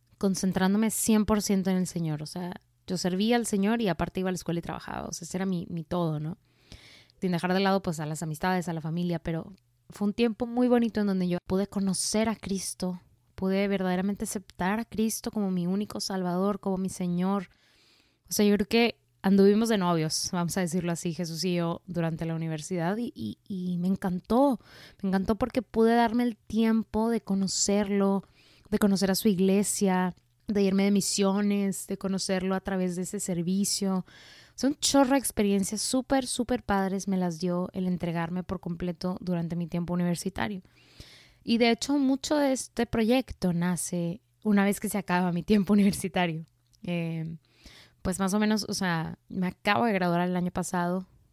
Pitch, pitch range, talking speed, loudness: 190 Hz, 175-210 Hz, 185 wpm, -28 LUFS